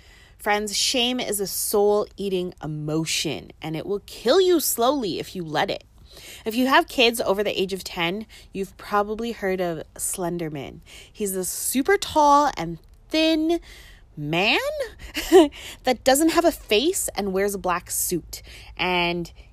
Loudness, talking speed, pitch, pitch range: -22 LUFS, 150 wpm, 205 Hz, 180-270 Hz